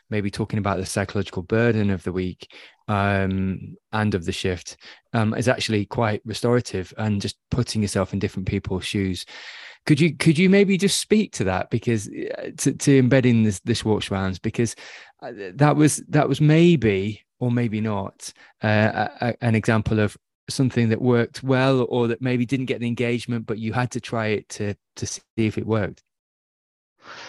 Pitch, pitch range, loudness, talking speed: 110 Hz, 100-125 Hz, -22 LUFS, 180 wpm